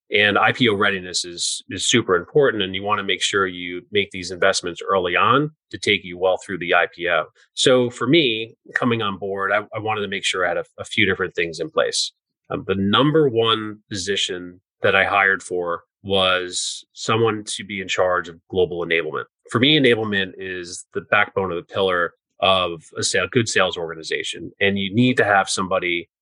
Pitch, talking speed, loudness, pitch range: 100 Hz, 195 wpm, -20 LUFS, 90-110 Hz